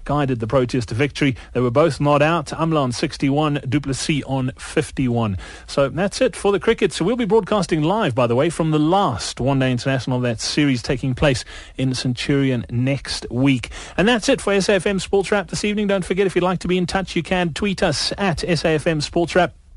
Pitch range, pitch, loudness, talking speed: 130-190 Hz, 150 Hz, -20 LUFS, 230 wpm